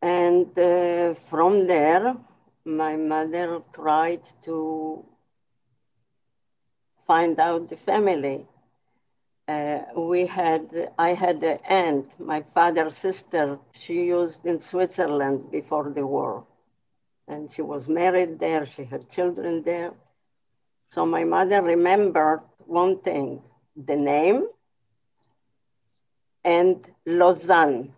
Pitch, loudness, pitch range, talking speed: 160 Hz, -23 LUFS, 140-175 Hz, 105 wpm